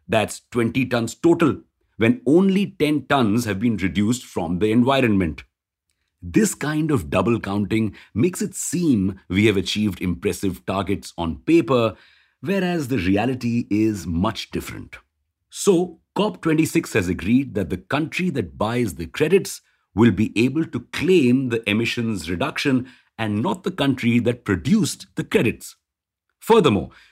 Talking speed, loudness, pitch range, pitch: 140 wpm, -21 LUFS, 95-140 Hz, 115 Hz